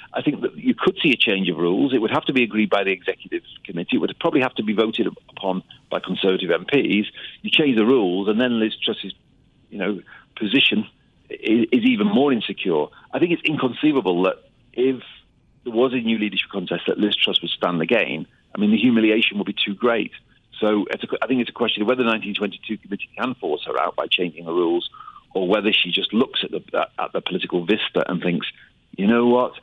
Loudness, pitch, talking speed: -21 LUFS, 115 Hz, 225 wpm